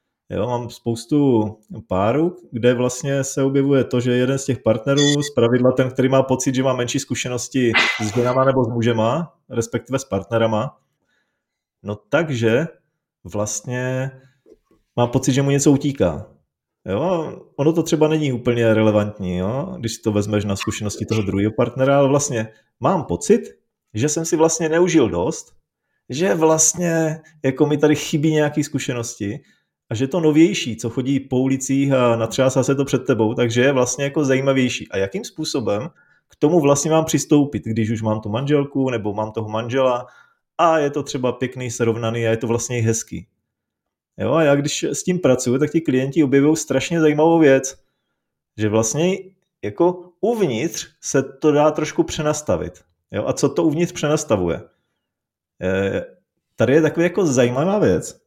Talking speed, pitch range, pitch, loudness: 165 wpm, 115-150 Hz, 130 Hz, -19 LUFS